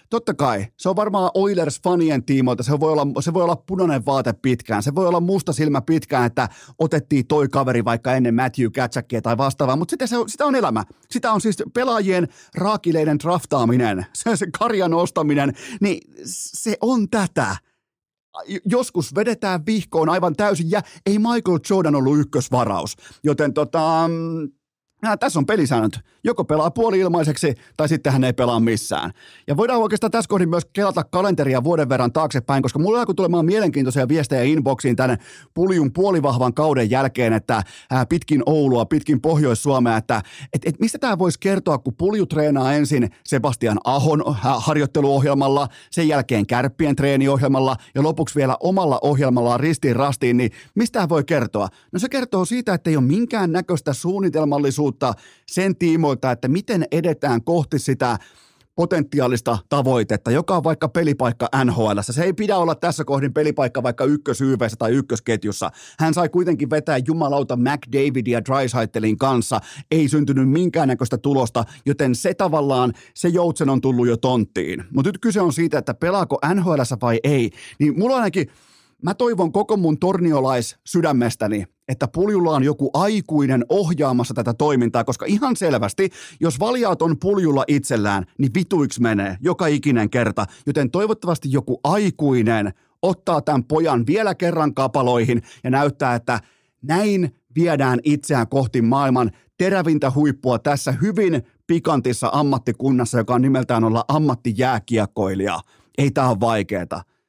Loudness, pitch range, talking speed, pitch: -20 LUFS, 125-170 Hz, 150 wpm, 145 Hz